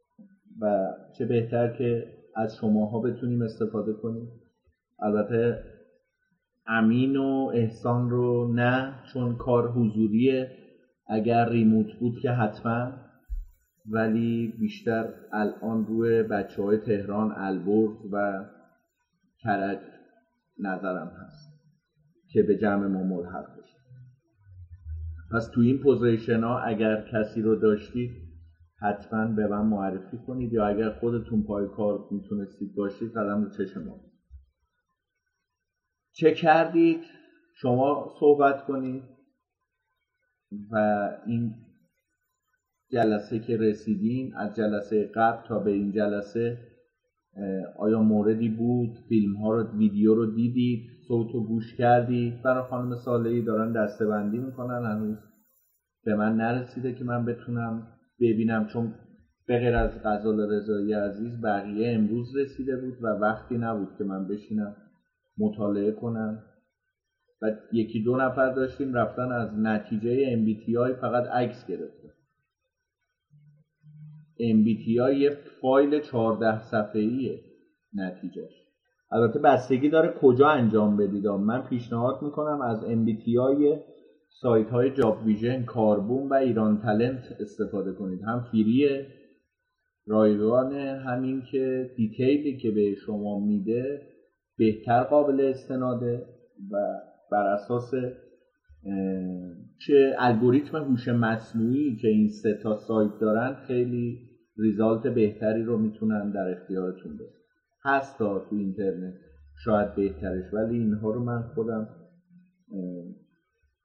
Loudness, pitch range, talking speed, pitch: -26 LUFS, 105-130 Hz, 110 wpm, 115 Hz